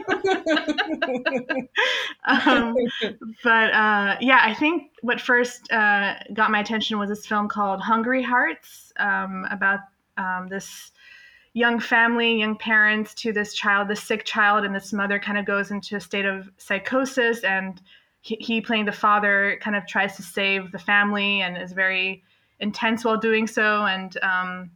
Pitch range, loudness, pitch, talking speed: 200-235 Hz, -22 LUFS, 215 Hz, 155 wpm